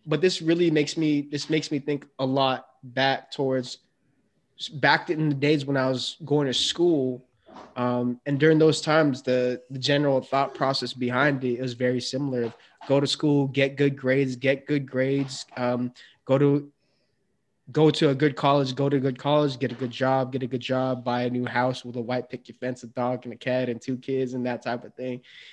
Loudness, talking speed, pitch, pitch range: -25 LUFS, 210 wpm, 135 Hz, 125-145 Hz